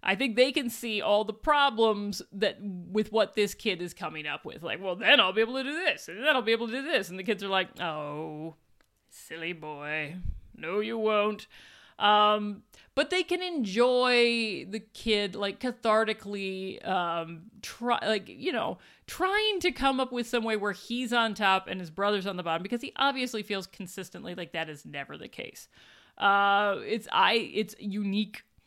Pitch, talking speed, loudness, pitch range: 210 Hz, 195 wpm, -28 LUFS, 190-240 Hz